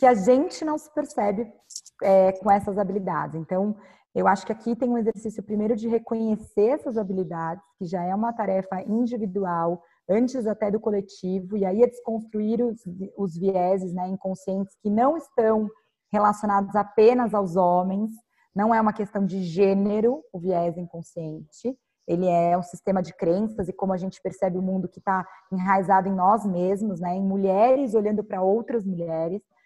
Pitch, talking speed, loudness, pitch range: 200 Hz, 170 wpm, -24 LUFS, 185-225 Hz